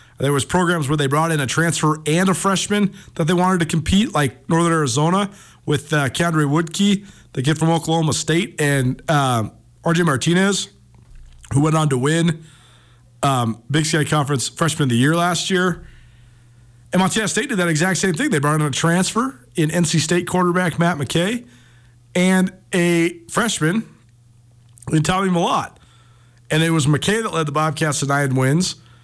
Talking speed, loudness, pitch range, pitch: 175 wpm, -18 LUFS, 135-175 Hz, 160 Hz